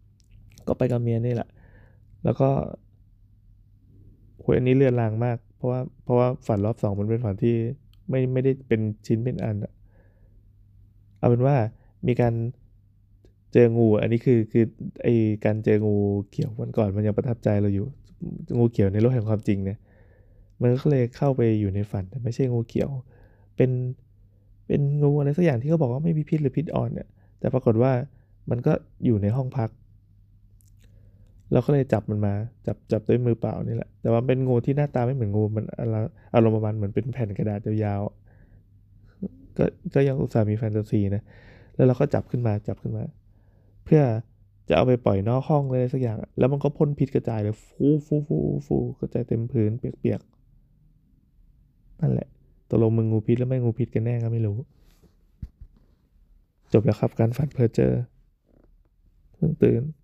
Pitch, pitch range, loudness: 110 Hz, 100-125 Hz, -24 LUFS